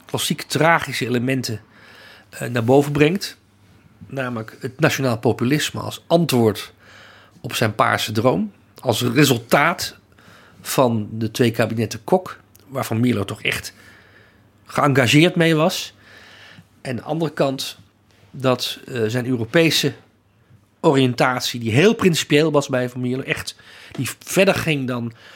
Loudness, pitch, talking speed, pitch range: -19 LUFS, 125 Hz, 120 wpm, 110-145 Hz